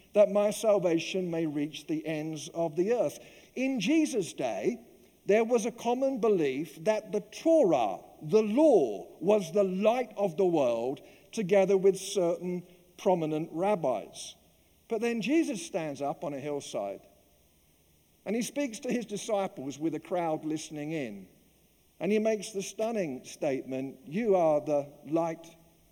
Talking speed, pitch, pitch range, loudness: 150 wpm, 190 Hz, 155-215 Hz, -30 LUFS